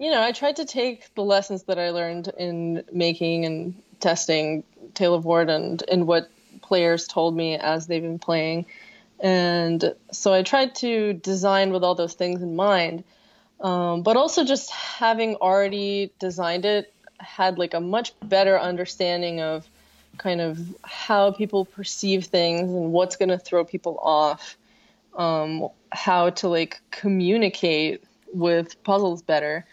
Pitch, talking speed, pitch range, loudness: 180 Hz, 155 wpm, 170-200 Hz, -23 LUFS